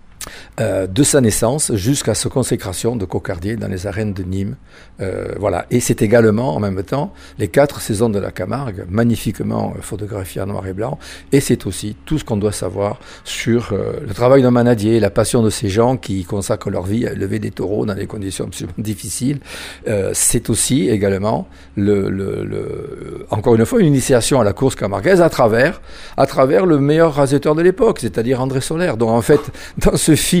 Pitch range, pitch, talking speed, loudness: 100-135 Hz, 115 Hz, 195 wpm, -17 LUFS